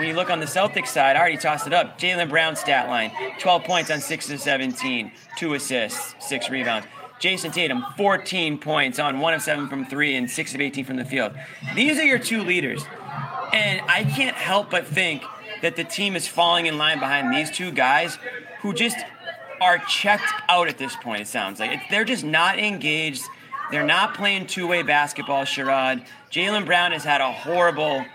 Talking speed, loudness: 200 wpm, -22 LUFS